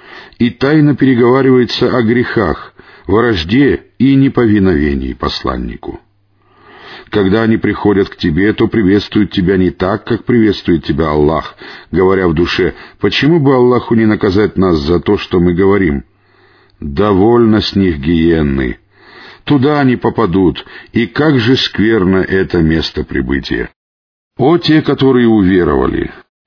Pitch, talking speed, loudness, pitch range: 105 Hz, 125 wpm, -12 LUFS, 85-125 Hz